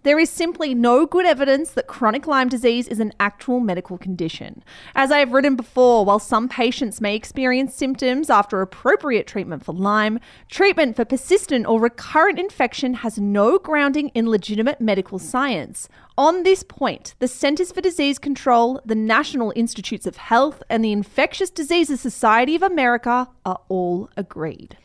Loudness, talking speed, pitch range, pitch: -19 LUFS, 160 wpm, 215-285 Hz, 250 Hz